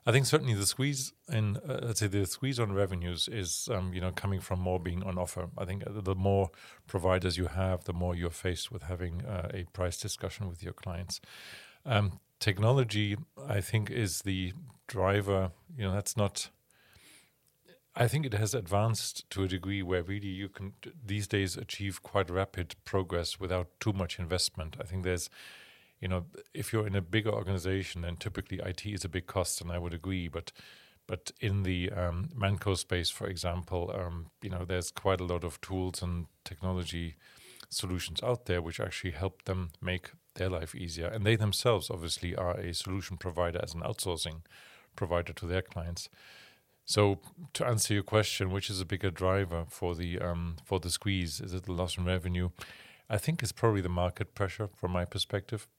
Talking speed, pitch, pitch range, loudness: 185 wpm, 95 Hz, 90-105 Hz, -33 LUFS